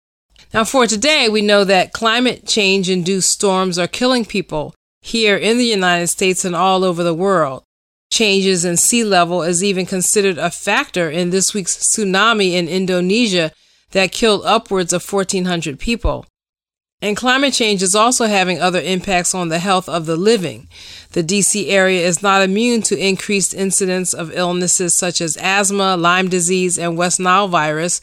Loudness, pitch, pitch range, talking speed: -15 LUFS, 190 Hz, 175-205 Hz, 165 wpm